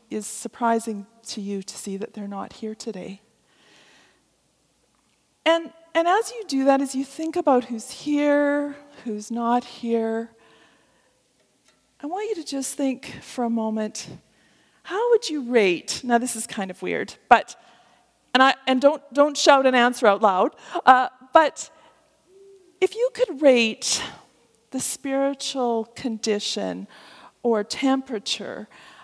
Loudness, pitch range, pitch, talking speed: -22 LUFS, 225-295 Hz, 260 Hz, 140 wpm